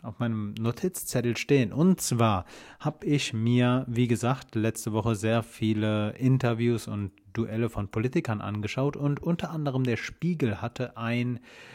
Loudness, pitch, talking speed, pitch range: -28 LUFS, 120 Hz, 145 wpm, 110-130 Hz